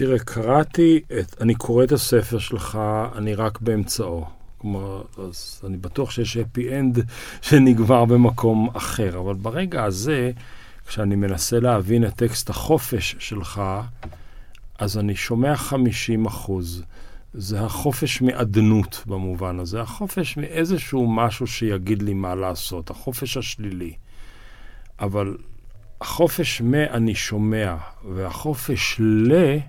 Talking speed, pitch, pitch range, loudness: 115 wpm, 110 Hz, 100-125 Hz, -22 LUFS